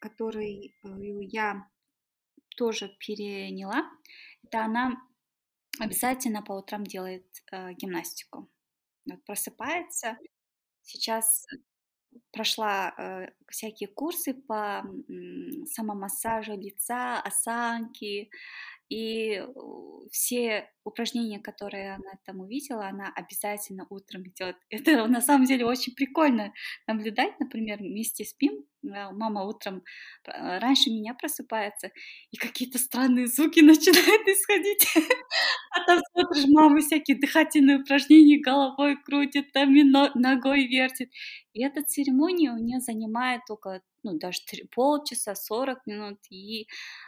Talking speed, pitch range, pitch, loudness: 100 wpm, 210-285 Hz, 240 Hz, -24 LUFS